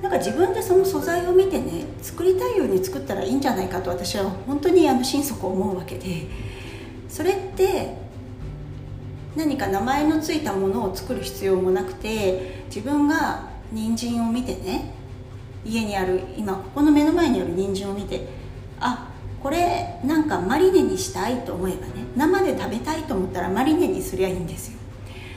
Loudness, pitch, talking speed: -23 LUFS, 235 Hz, 335 characters per minute